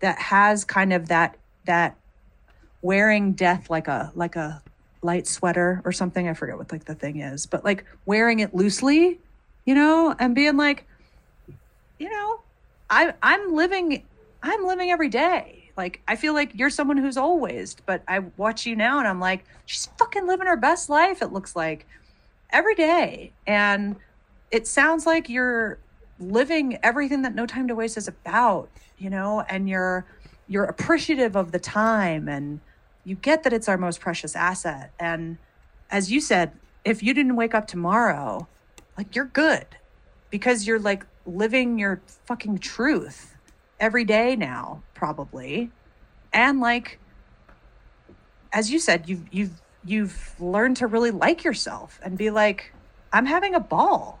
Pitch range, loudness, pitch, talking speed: 185-275 Hz, -23 LUFS, 215 Hz, 160 wpm